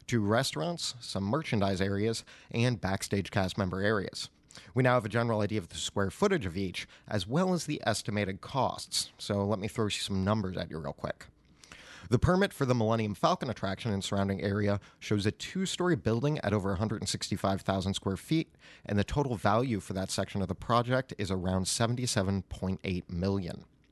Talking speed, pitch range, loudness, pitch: 180 wpm, 95-120 Hz, -31 LUFS, 105 Hz